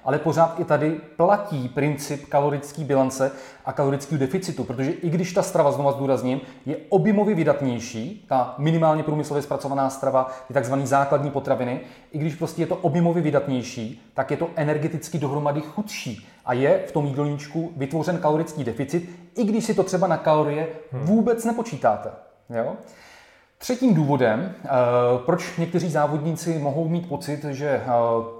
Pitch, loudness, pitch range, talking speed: 150 Hz, -23 LUFS, 135-170 Hz, 150 wpm